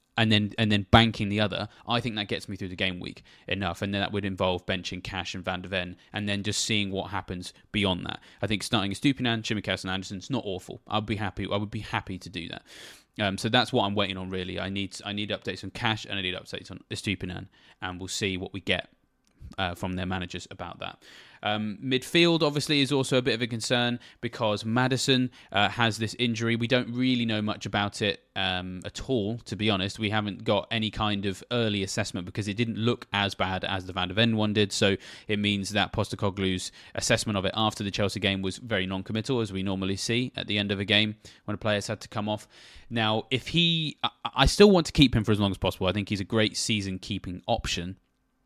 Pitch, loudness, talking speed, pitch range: 105 Hz, -27 LUFS, 245 wpm, 95-115 Hz